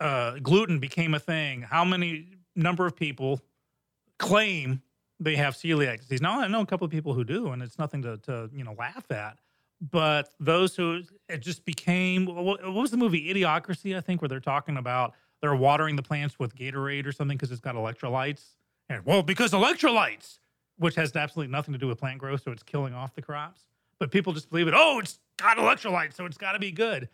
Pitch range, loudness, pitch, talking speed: 135-180 Hz, -27 LUFS, 150 Hz, 210 wpm